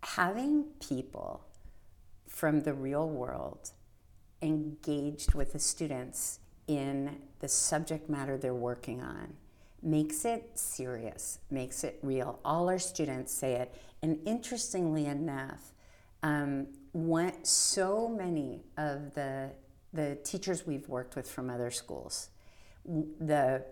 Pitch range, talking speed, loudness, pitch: 125-155 Hz, 115 wpm, -34 LUFS, 145 Hz